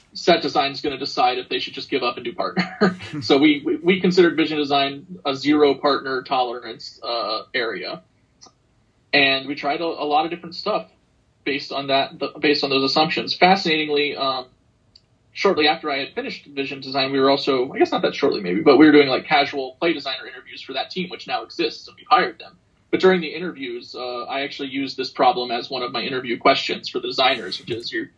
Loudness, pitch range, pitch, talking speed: -20 LUFS, 135-175 Hz, 145 Hz, 225 wpm